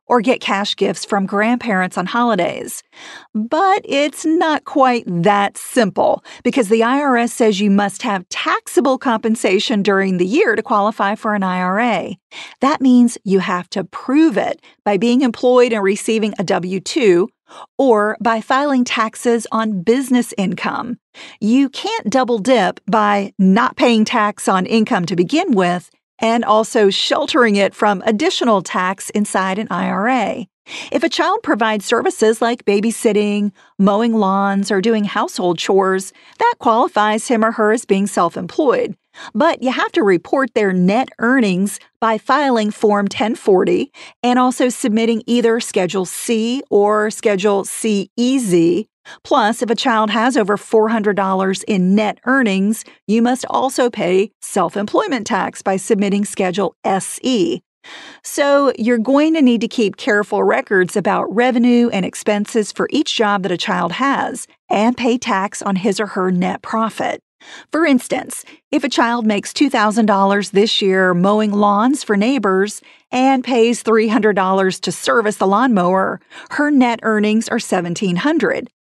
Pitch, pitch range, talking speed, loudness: 220 Hz, 200-255 Hz, 150 wpm, -16 LUFS